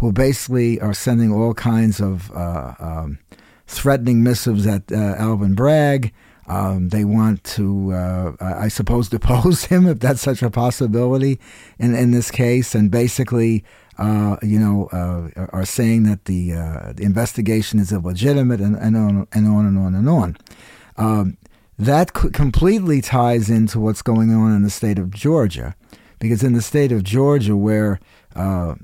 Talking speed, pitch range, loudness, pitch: 165 wpm, 100-120 Hz, -18 LUFS, 110 Hz